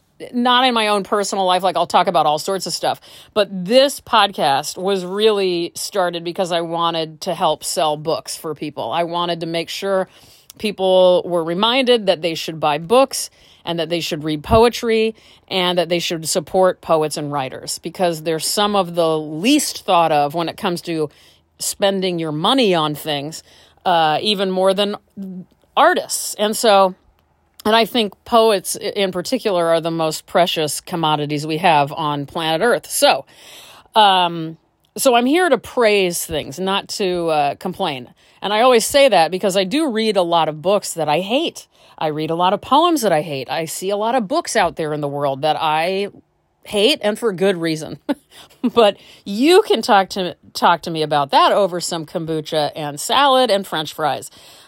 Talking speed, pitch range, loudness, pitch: 185 wpm, 160-205 Hz, -17 LUFS, 180 Hz